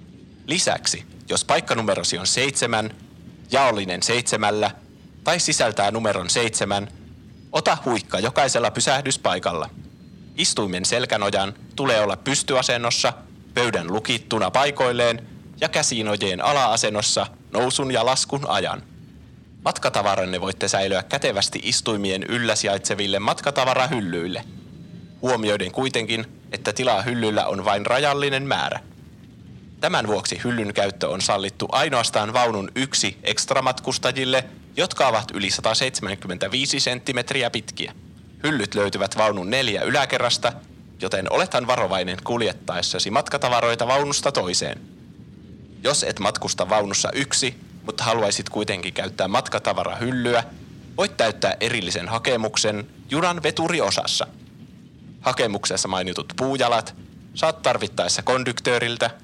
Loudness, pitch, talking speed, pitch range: -22 LUFS, 115 Hz, 100 wpm, 100-130 Hz